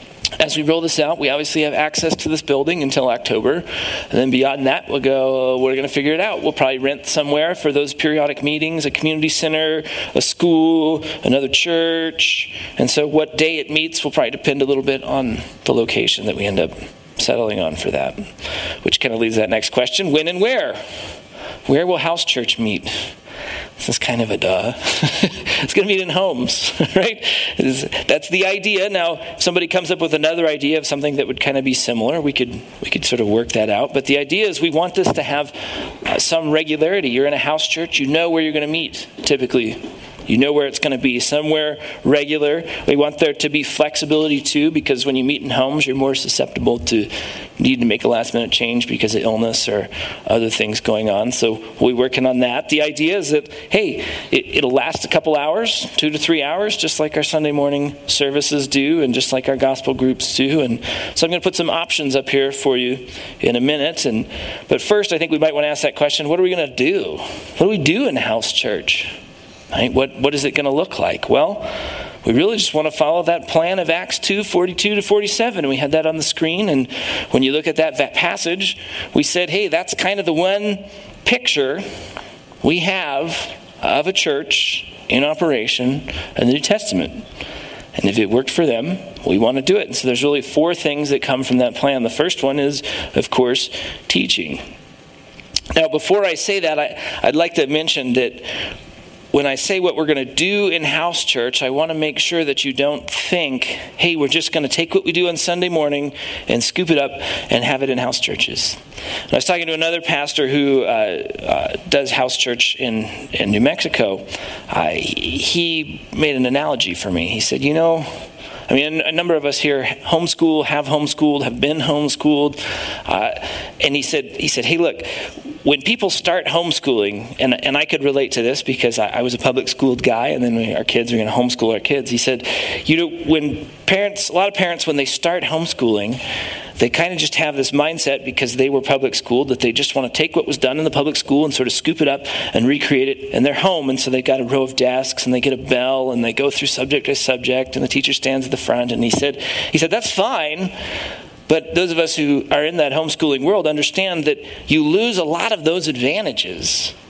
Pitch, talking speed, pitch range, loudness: 150 Hz, 220 wpm, 135-165 Hz, -17 LUFS